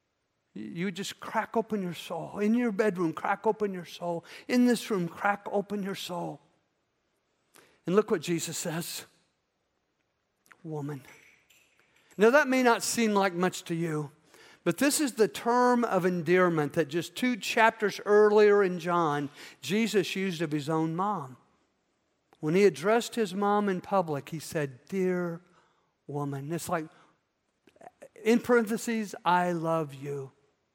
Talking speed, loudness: 140 wpm, -28 LUFS